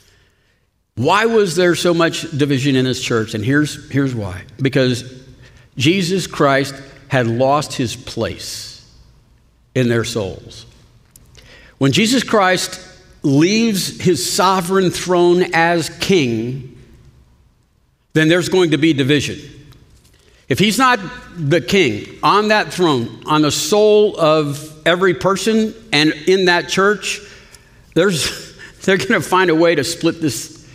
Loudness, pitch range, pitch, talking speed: -16 LUFS, 125-185 Hz, 155 Hz, 130 wpm